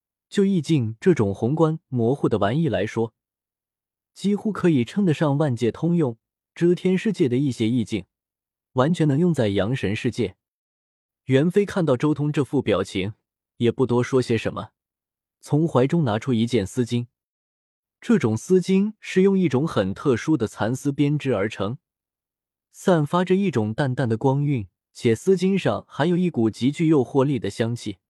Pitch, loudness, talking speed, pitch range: 130 Hz, -22 LUFS, 240 characters per minute, 110-160 Hz